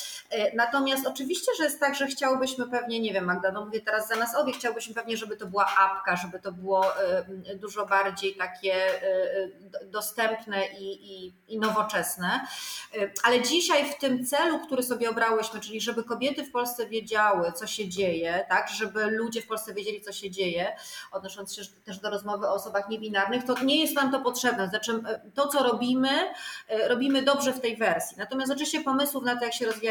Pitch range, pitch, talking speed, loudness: 200-265 Hz, 225 Hz, 180 wpm, -27 LUFS